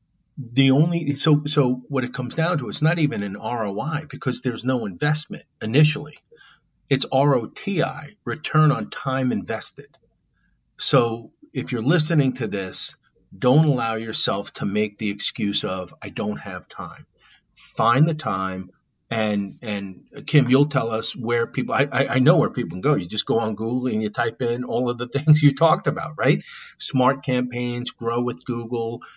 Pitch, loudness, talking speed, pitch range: 125 Hz, -22 LUFS, 170 wpm, 115-145 Hz